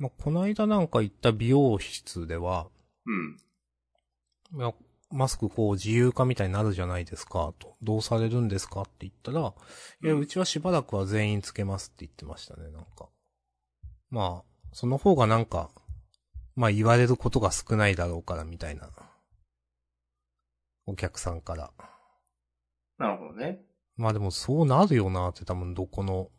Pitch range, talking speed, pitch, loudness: 85-120 Hz, 315 characters per minute, 100 Hz, -28 LUFS